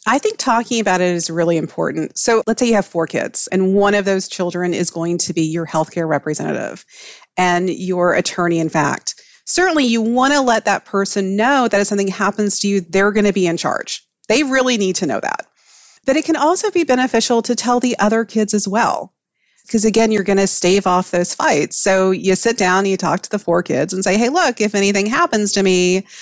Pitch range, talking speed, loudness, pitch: 180-230 Hz, 225 wpm, -16 LUFS, 200 Hz